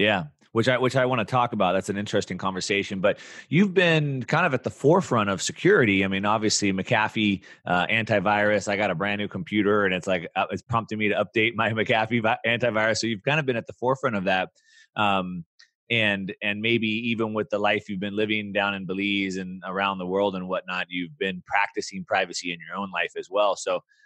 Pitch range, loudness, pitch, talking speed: 100-115 Hz, -24 LUFS, 105 Hz, 215 wpm